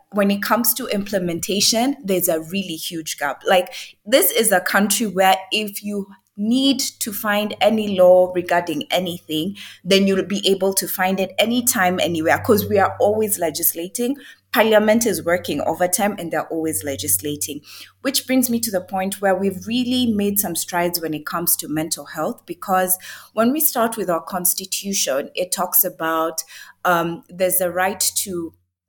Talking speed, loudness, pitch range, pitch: 165 wpm, -19 LUFS, 175-210 Hz, 190 Hz